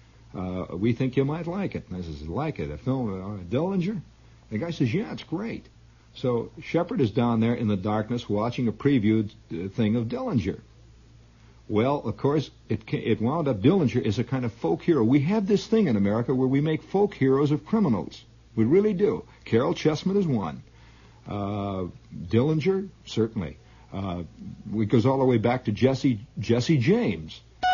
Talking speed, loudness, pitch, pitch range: 190 wpm, -26 LUFS, 120 Hz, 110-150 Hz